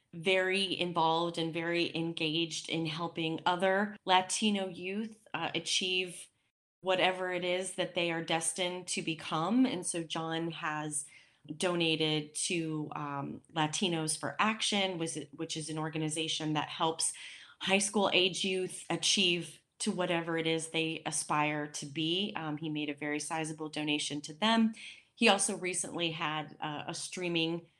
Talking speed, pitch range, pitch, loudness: 140 wpm, 155-185 Hz, 165 Hz, -32 LUFS